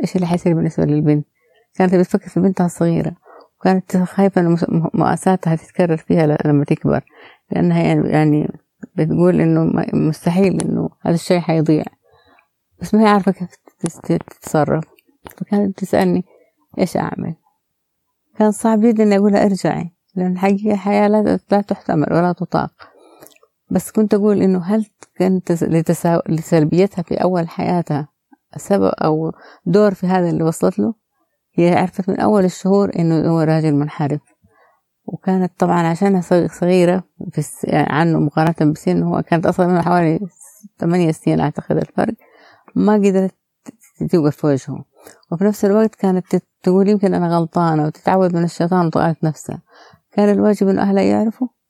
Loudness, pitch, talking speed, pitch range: -17 LUFS, 180 Hz, 135 wpm, 160-200 Hz